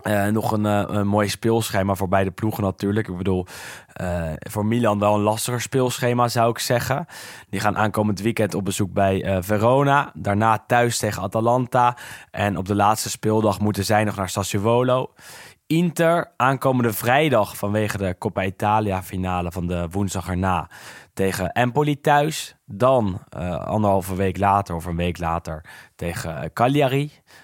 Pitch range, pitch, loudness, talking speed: 95-120 Hz, 105 Hz, -21 LUFS, 155 wpm